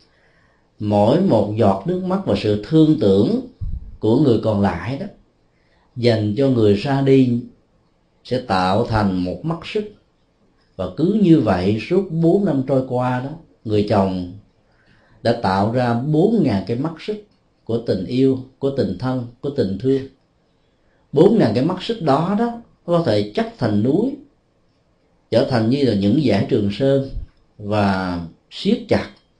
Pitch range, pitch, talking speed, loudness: 105-150 Hz, 120 Hz, 155 wpm, -19 LUFS